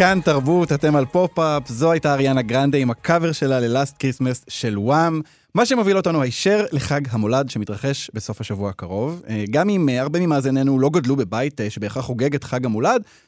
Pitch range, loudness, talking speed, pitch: 125-160 Hz, -20 LUFS, 170 wpm, 135 Hz